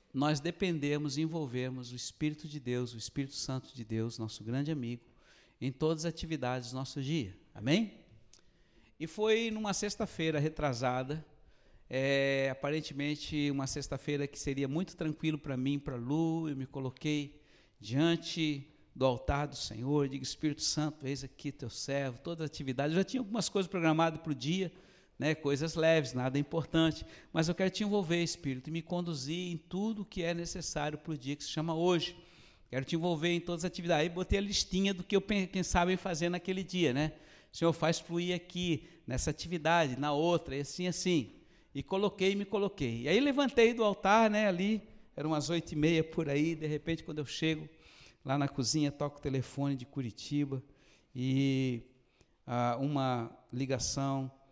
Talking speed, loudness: 180 wpm, -34 LUFS